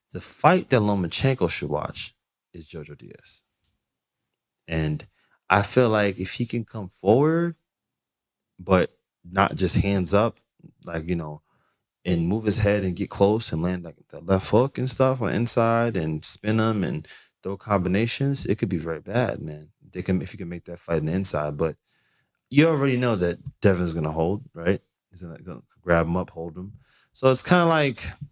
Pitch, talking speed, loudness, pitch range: 100 Hz, 195 wpm, -23 LUFS, 85-120 Hz